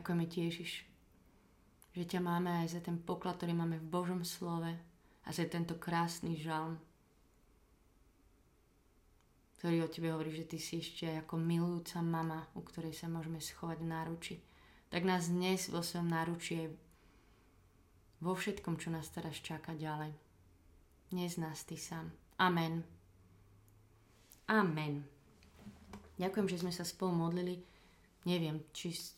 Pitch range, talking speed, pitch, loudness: 155-175 Hz, 135 wpm, 165 Hz, -39 LUFS